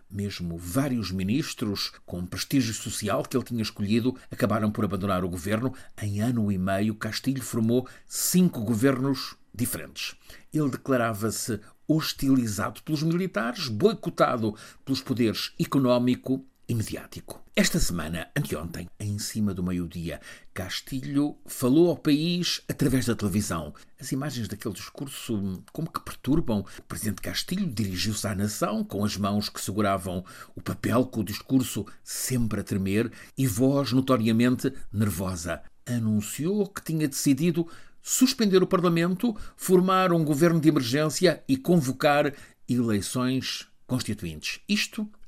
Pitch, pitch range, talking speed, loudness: 125 Hz, 105-145 Hz, 125 wpm, -27 LUFS